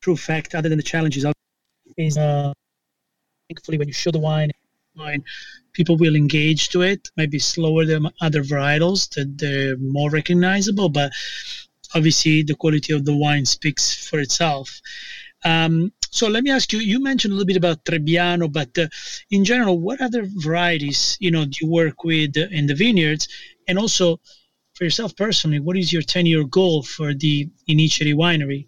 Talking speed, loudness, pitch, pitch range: 170 wpm, -19 LUFS, 160 Hz, 150-180 Hz